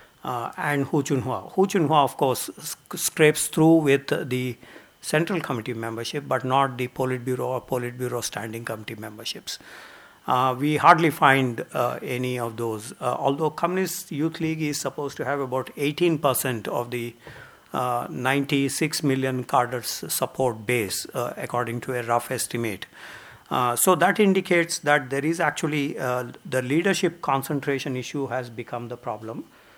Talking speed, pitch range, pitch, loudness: 155 wpm, 125-155 Hz, 135 Hz, -24 LUFS